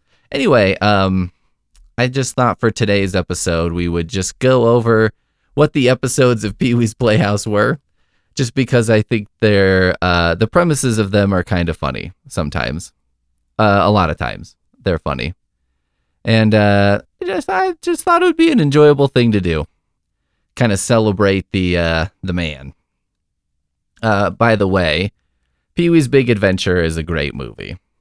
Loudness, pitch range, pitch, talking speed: -15 LUFS, 80-120 Hz, 95 Hz, 165 wpm